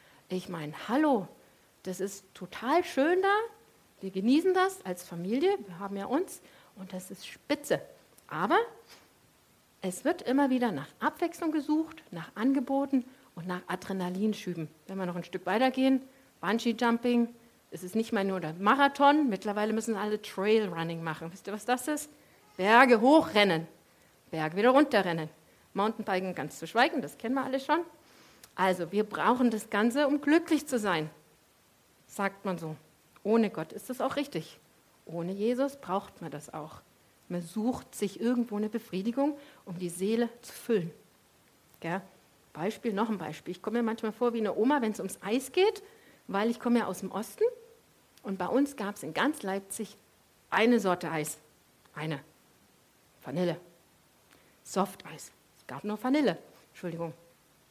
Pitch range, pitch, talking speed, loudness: 185-265 Hz, 215 Hz, 160 wpm, -30 LUFS